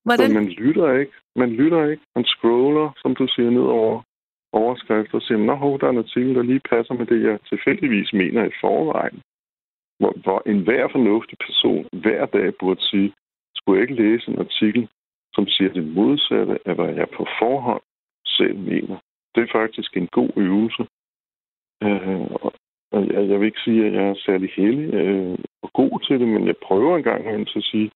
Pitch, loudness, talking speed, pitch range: 110 Hz, -20 LUFS, 185 wpm, 100-125 Hz